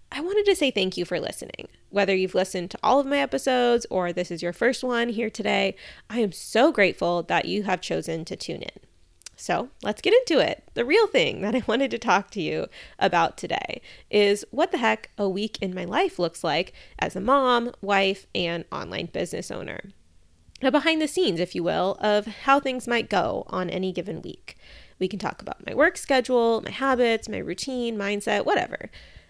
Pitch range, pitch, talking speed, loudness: 185-260 Hz, 215 Hz, 205 wpm, -24 LUFS